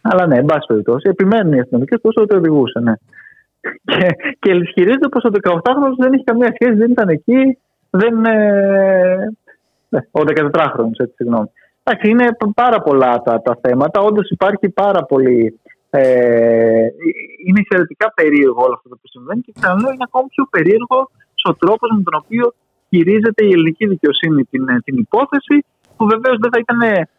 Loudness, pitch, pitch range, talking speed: -14 LUFS, 195 Hz, 145-235 Hz, 165 wpm